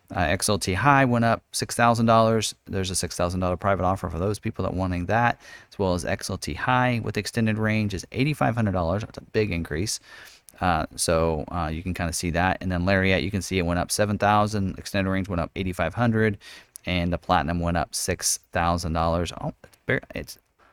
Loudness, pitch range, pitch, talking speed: -24 LUFS, 85-110 Hz, 95 Hz, 225 wpm